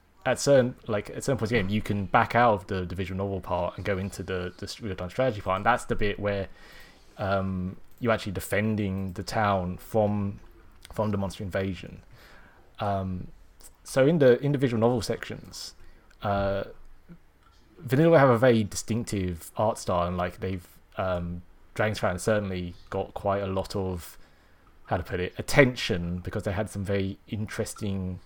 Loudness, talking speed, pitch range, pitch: -27 LUFS, 170 wpm, 90-110 Hz, 100 Hz